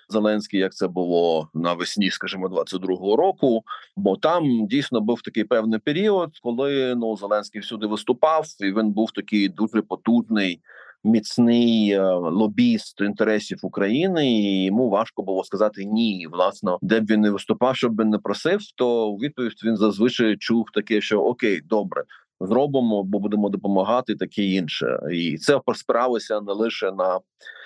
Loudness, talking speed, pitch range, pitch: -22 LUFS, 150 wpm, 100-120 Hz, 110 Hz